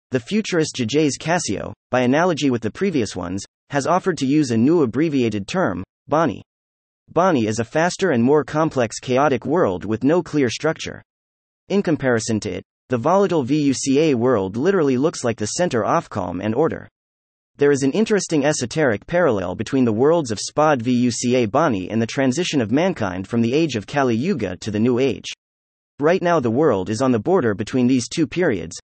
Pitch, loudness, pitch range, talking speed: 130 Hz, -20 LUFS, 110-155 Hz, 185 wpm